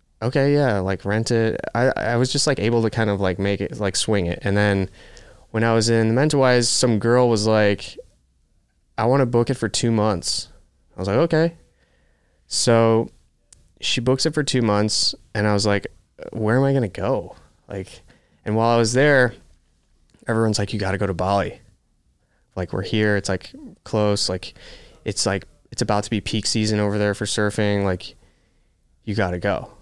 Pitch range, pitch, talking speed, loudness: 95-115 Hz, 105 Hz, 195 wpm, -21 LUFS